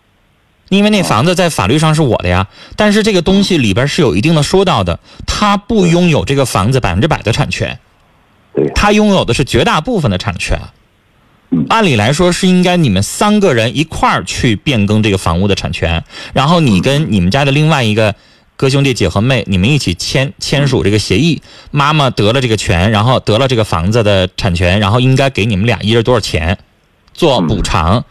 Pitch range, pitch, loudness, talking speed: 100-155 Hz, 120 Hz, -11 LUFS, 305 characters per minute